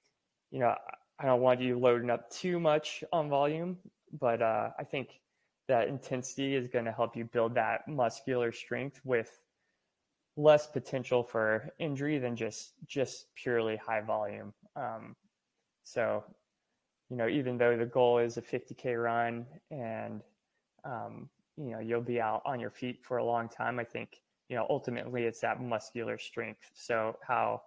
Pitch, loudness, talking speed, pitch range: 125 Hz, -33 LUFS, 165 wpm, 115-135 Hz